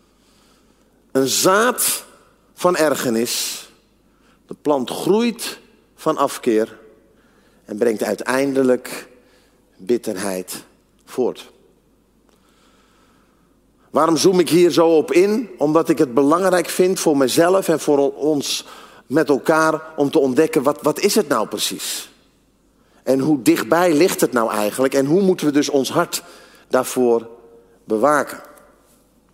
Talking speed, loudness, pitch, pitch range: 120 wpm, -18 LUFS, 145 Hz, 120-165 Hz